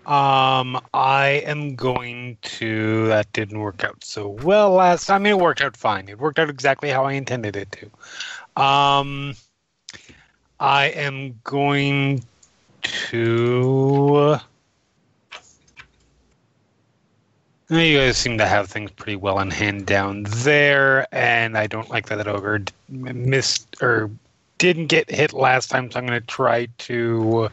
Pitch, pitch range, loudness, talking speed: 125 Hz, 110-140 Hz, -19 LUFS, 140 wpm